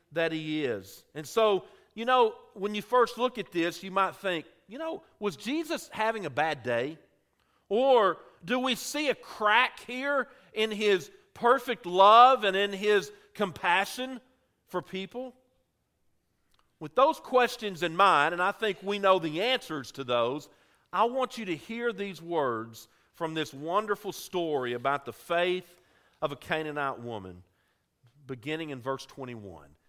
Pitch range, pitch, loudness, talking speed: 150-235 Hz, 190 Hz, -28 LUFS, 155 wpm